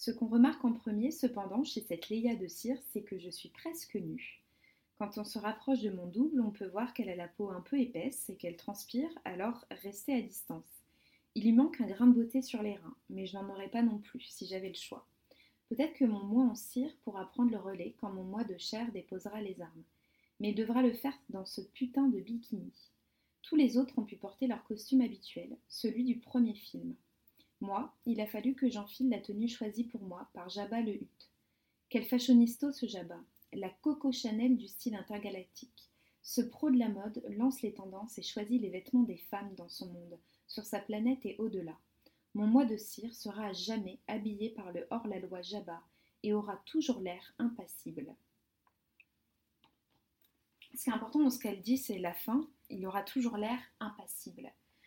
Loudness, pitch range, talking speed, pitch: -36 LUFS, 200-250 Hz, 200 wpm, 220 Hz